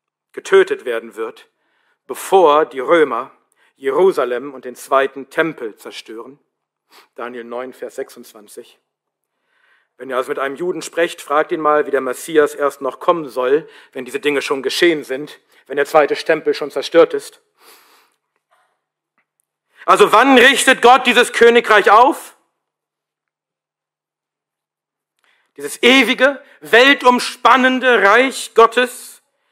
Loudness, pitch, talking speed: -14 LUFS, 245 Hz, 120 wpm